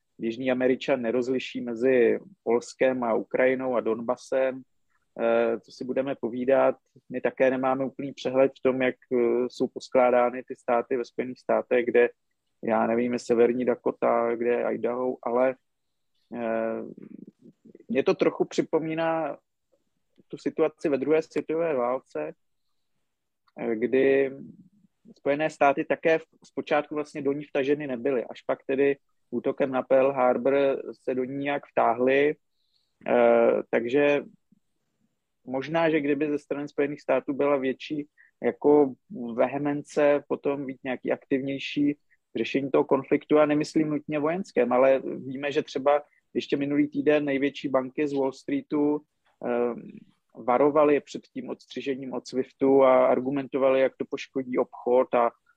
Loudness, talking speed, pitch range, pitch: -26 LUFS, 130 wpm, 125-145 Hz, 135 Hz